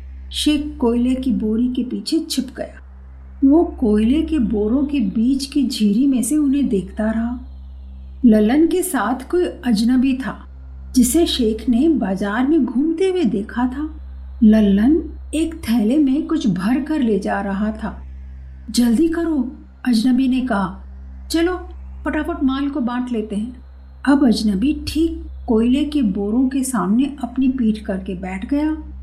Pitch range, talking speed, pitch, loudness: 205-285 Hz, 150 wpm, 245 Hz, -18 LUFS